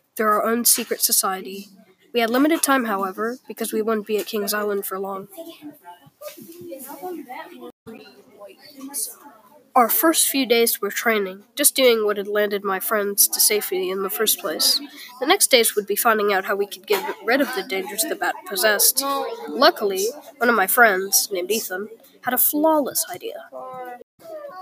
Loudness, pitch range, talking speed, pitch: -19 LUFS, 205-295 Hz, 165 wpm, 235 Hz